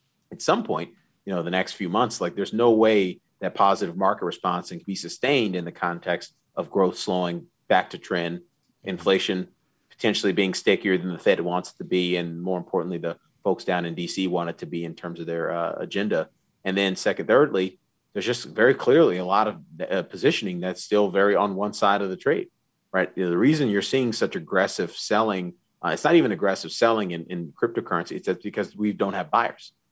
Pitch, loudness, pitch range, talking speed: 90 Hz, -24 LUFS, 85-100 Hz, 210 wpm